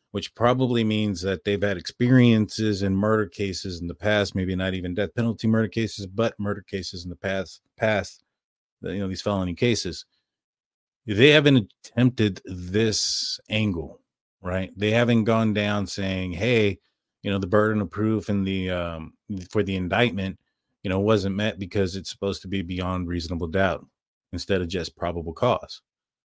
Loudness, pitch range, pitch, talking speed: -24 LUFS, 95-110 Hz, 100 Hz, 165 wpm